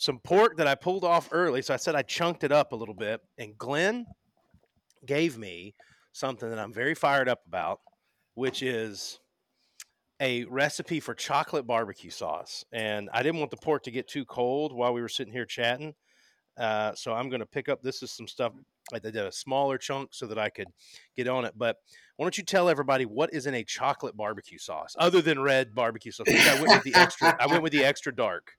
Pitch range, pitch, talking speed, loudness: 120-155 Hz, 135 Hz, 220 wpm, -27 LUFS